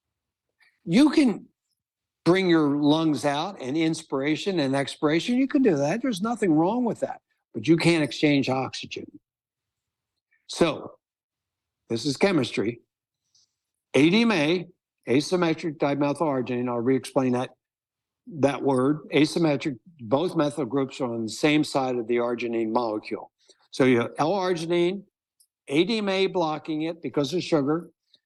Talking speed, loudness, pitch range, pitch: 125 wpm, -24 LUFS, 130-180 Hz, 150 Hz